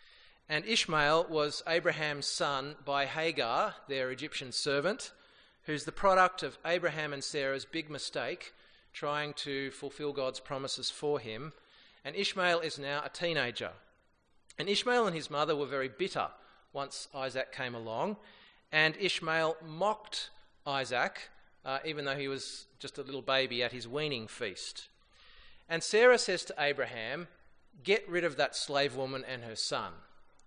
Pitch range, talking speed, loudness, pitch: 135-165 Hz, 150 wpm, -33 LUFS, 145 Hz